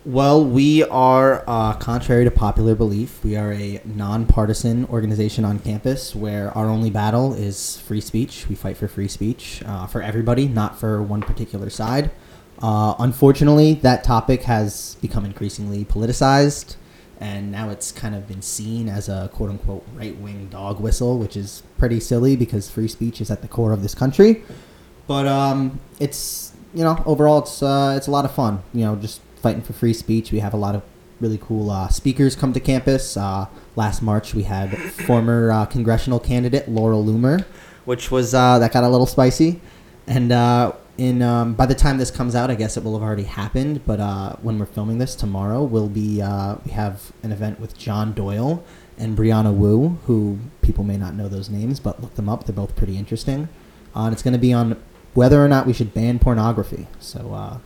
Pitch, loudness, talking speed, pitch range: 115 Hz, -20 LUFS, 195 wpm, 105-130 Hz